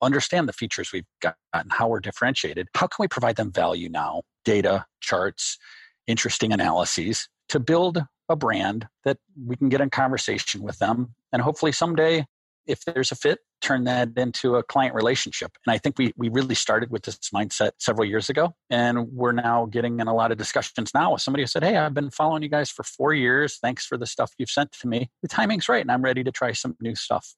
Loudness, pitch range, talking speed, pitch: -24 LUFS, 120-145 Hz, 220 wpm, 130 Hz